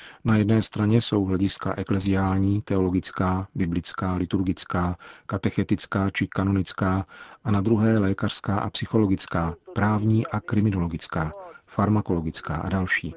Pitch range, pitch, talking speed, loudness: 95-105 Hz, 95 Hz, 110 wpm, -24 LUFS